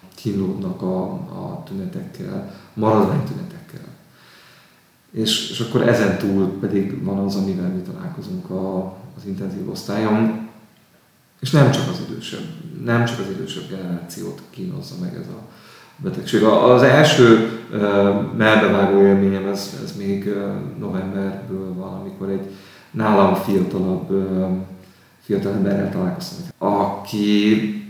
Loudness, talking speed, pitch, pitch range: -19 LUFS, 115 wpm, 105 Hz, 95-150 Hz